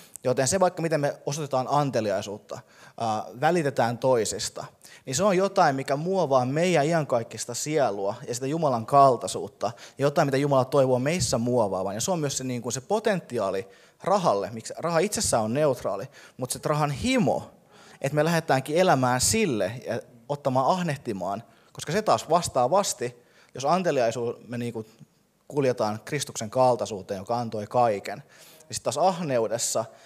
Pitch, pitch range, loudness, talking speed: 130 Hz, 120-150 Hz, -25 LUFS, 150 wpm